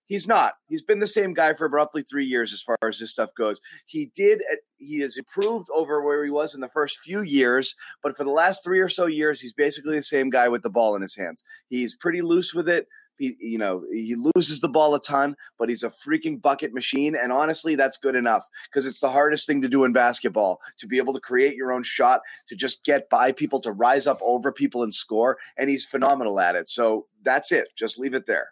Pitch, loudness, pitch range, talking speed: 145 Hz, -23 LUFS, 130-175 Hz, 245 wpm